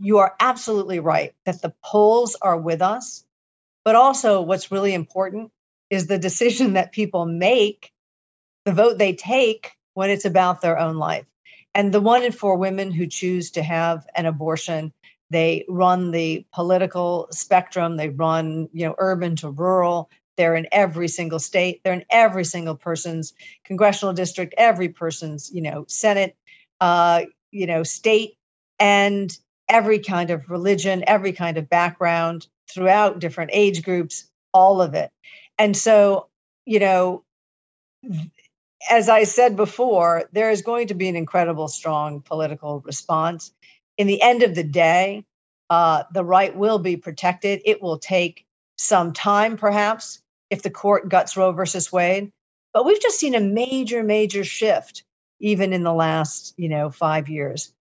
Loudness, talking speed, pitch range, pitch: -20 LUFS, 155 wpm, 165-205 Hz, 185 Hz